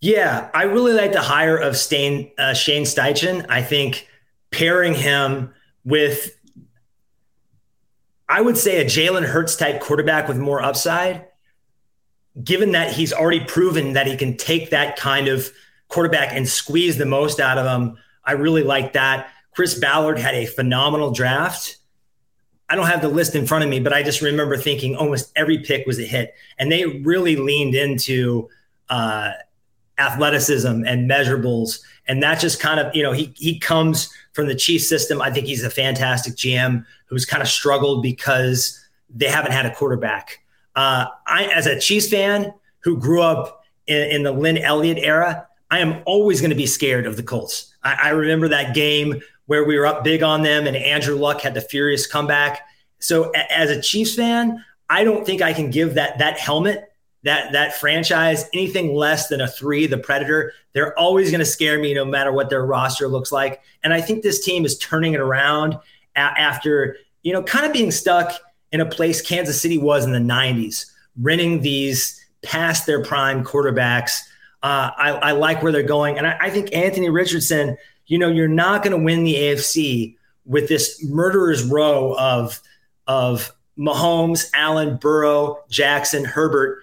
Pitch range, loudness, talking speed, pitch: 135-165 Hz, -18 LUFS, 180 wpm, 150 Hz